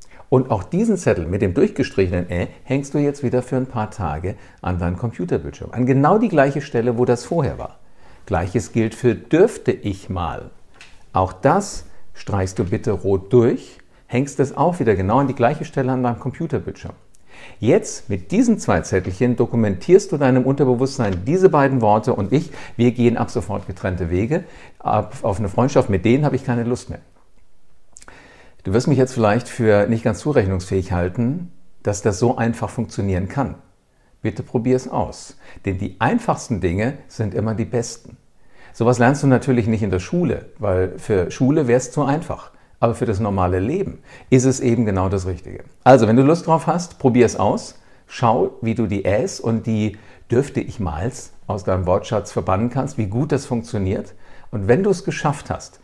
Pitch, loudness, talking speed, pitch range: 120 Hz, -19 LUFS, 185 wpm, 100-130 Hz